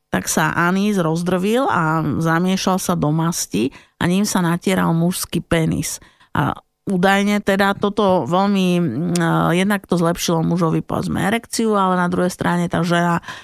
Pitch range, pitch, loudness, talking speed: 170-195 Hz, 180 Hz, -18 LUFS, 145 wpm